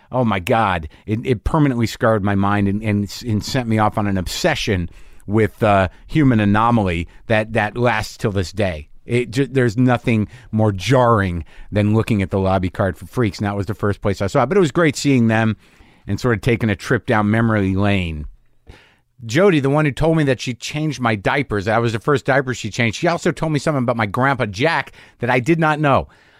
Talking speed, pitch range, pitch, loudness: 225 wpm, 100-130 Hz, 110 Hz, -18 LUFS